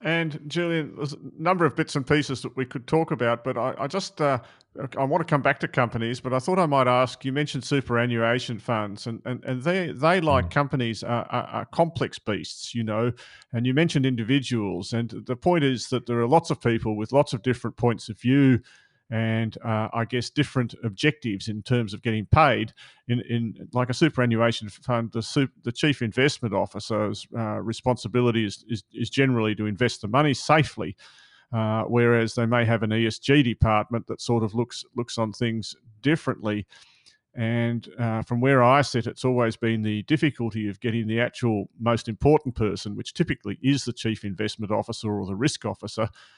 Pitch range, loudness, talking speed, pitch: 110-135 Hz, -25 LUFS, 195 wpm, 120 Hz